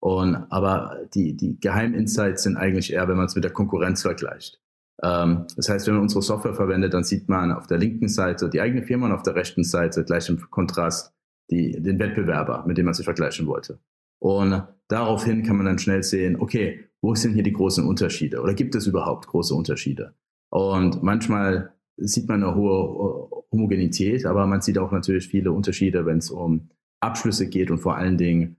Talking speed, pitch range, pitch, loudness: 195 wpm, 90-105 Hz, 95 Hz, -23 LUFS